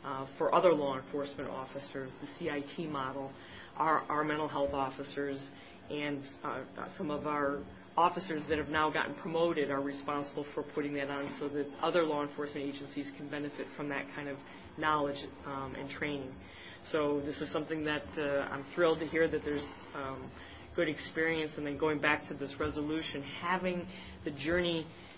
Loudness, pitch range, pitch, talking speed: -35 LUFS, 140-155 Hz, 145 Hz, 170 wpm